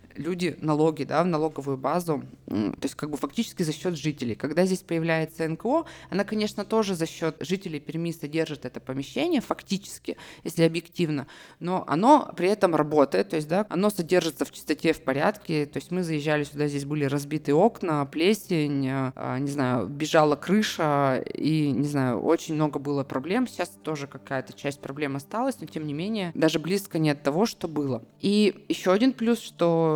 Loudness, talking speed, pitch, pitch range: -26 LUFS, 175 wpm, 160 Hz, 145-185 Hz